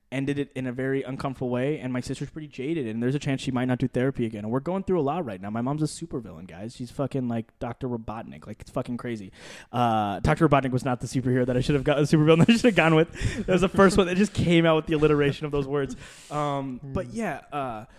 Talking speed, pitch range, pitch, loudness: 275 wpm, 125-150 Hz, 135 Hz, -25 LUFS